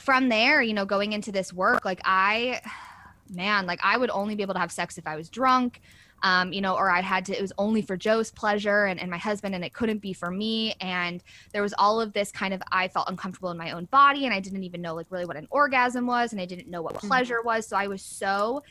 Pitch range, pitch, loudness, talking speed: 185-225 Hz, 200 Hz, -25 LUFS, 270 wpm